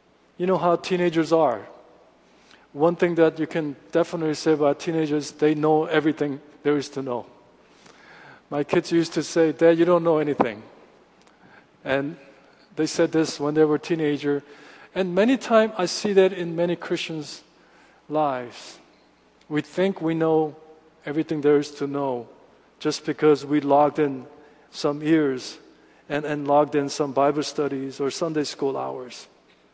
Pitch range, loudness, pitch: 145-165 Hz, -23 LUFS, 155 Hz